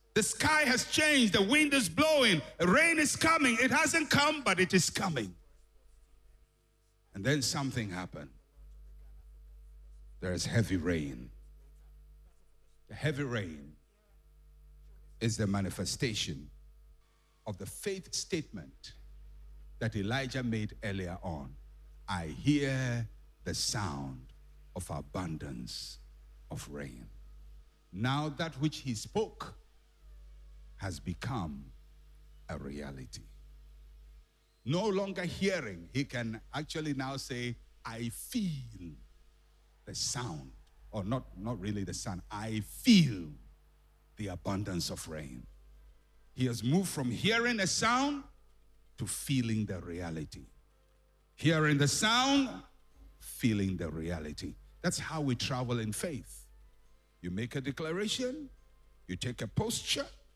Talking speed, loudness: 115 wpm, -32 LUFS